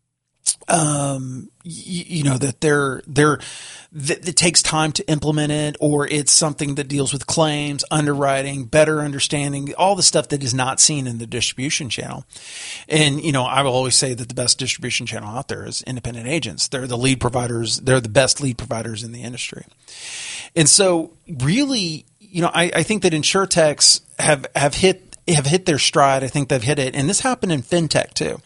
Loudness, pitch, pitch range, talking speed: -18 LUFS, 145 Hz, 130-160 Hz, 195 wpm